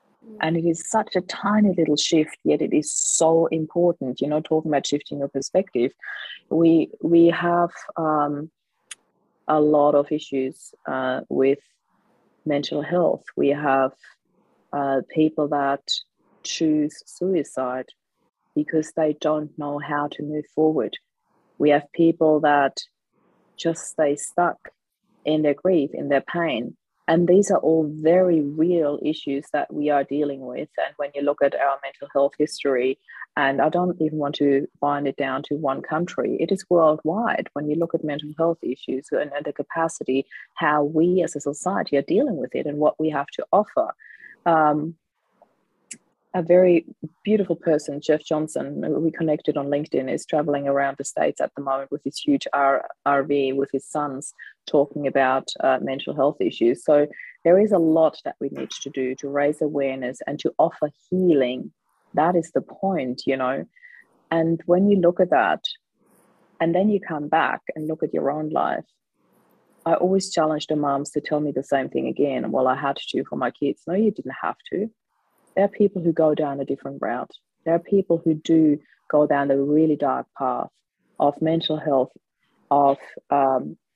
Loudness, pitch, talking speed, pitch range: -22 LUFS, 150 Hz, 175 wpm, 140-165 Hz